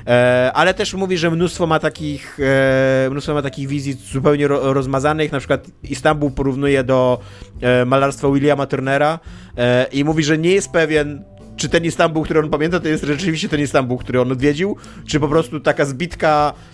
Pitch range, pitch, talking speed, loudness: 135-155 Hz, 145 Hz, 165 wpm, -17 LUFS